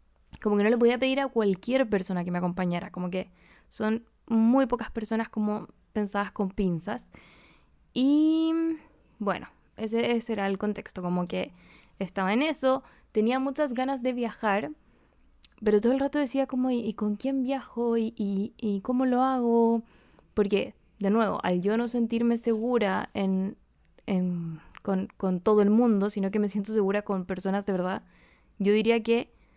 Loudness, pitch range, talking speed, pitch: -27 LUFS, 200-245 Hz, 170 wpm, 215 Hz